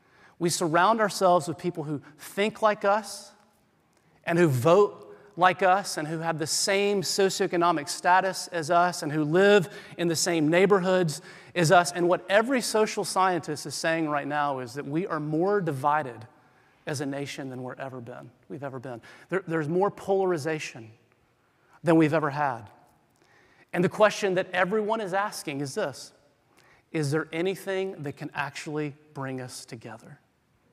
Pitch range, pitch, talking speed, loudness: 145-190 Hz, 165 Hz, 160 wpm, -26 LUFS